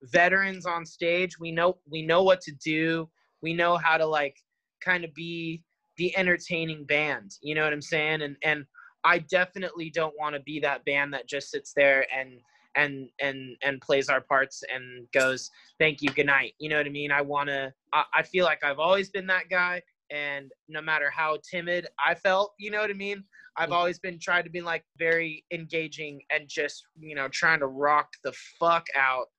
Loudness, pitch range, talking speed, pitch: -27 LUFS, 145-175 Hz, 205 wpm, 155 Hz